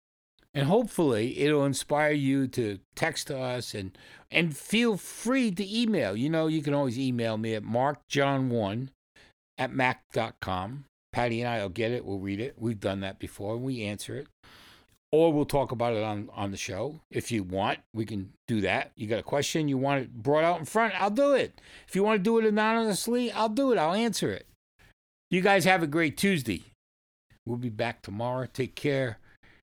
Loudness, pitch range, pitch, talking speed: -28 LUFS, 110-165 Hz, 135 Hz, 195 wpm